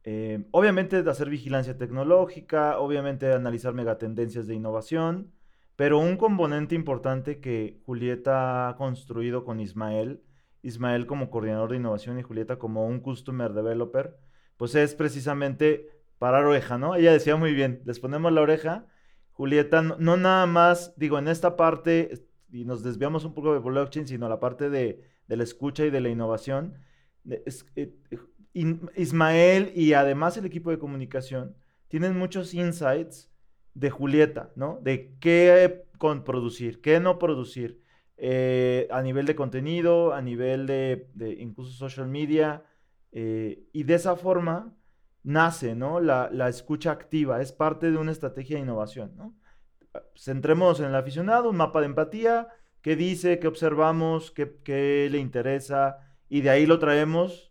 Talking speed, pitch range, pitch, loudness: 155 wpm, 125-165 Hz, 140 Hz, -25 LUFS